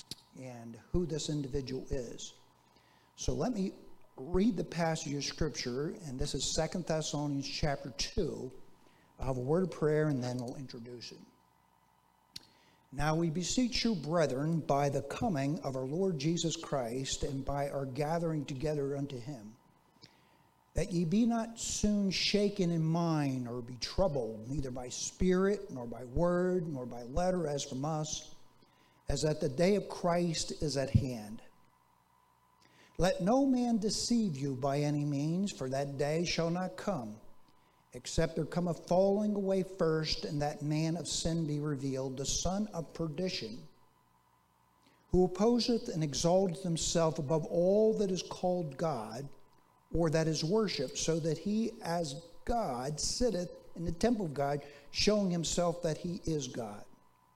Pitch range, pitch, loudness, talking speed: 135-180 Hz, 155 Hz, -34 LUFS, 155 wpm